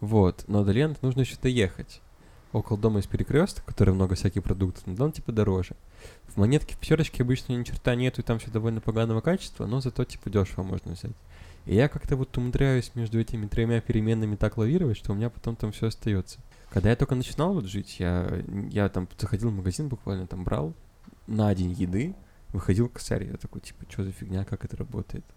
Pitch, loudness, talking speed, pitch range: 110 Hz, -28 LUFS, 205 wpm, 100-125 Hz